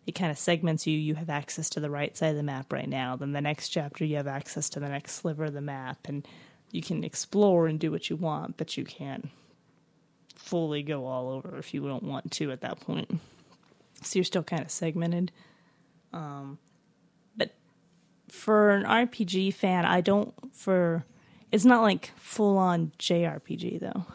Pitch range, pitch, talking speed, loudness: 145-185 Hz, 165 Hz, 190 wpm, -29 LUFS